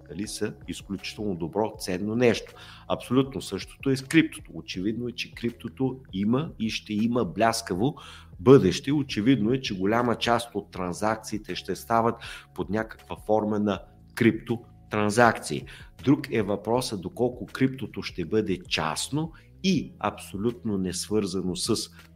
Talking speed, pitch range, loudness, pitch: 130 wpm, 90-120 Hz, -27 LUFS, 105 Hz